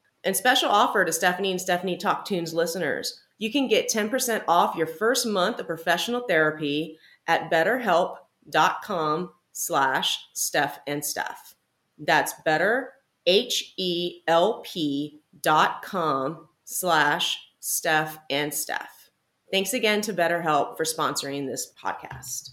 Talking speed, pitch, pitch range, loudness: 110 wpm, 170 Hz, 155-190 Hz, -24 LUFS